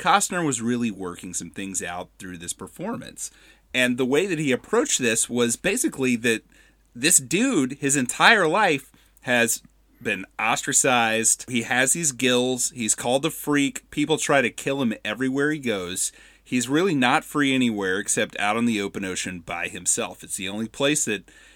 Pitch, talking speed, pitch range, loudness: 120 Hz, 175 wpm, 105-140 Hz, -22 LUFS